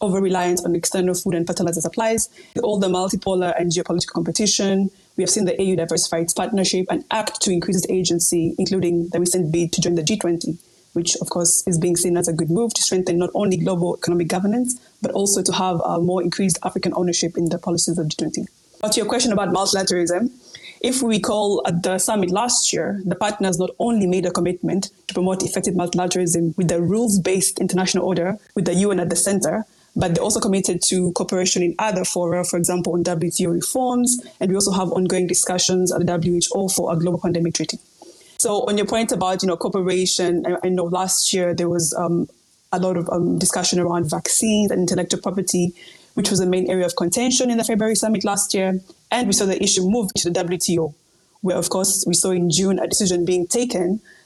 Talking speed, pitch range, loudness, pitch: 210 wpm, 175-195 Hz, -20 LUFS, 185 Hz